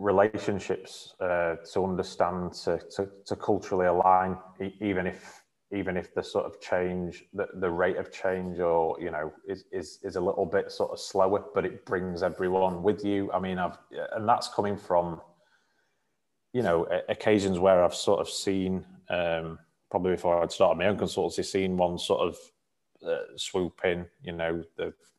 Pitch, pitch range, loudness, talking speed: 95 Hz, 85-100 Hz, -29 LUFS, 175 wpm